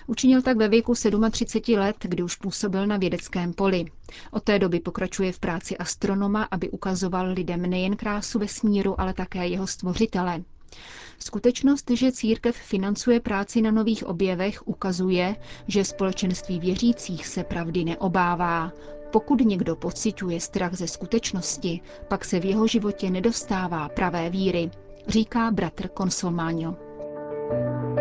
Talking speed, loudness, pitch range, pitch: 130 wpm, -25 LUFS, 180-215 Hz, 190 Hz